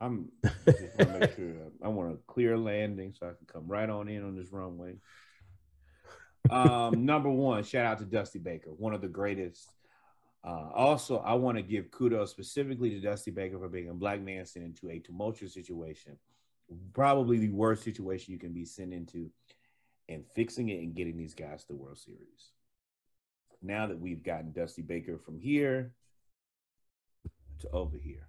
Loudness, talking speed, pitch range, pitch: -32 LUFS, 180 wpm, 85-110 Hz, 95 Hz